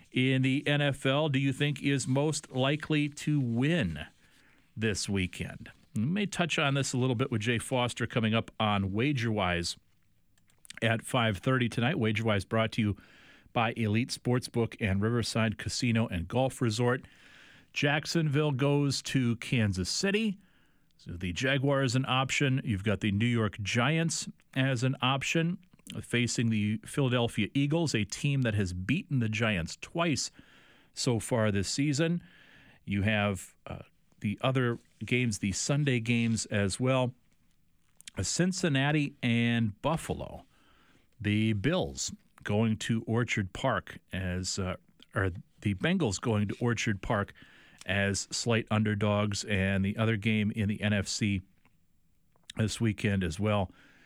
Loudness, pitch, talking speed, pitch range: -30 LUFS, 115 Hz, 135 wpm, 105-135 Hz